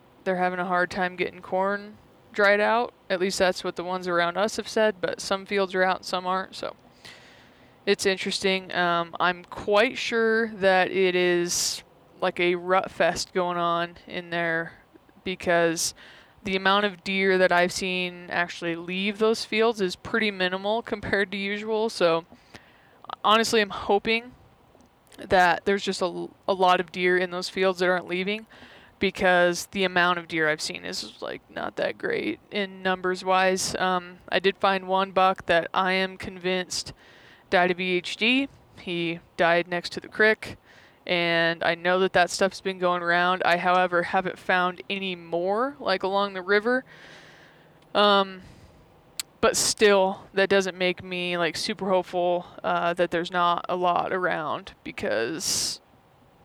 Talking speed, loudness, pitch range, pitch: 160 wpm, -24 LUFS, 175-200 Hz, 185 Hz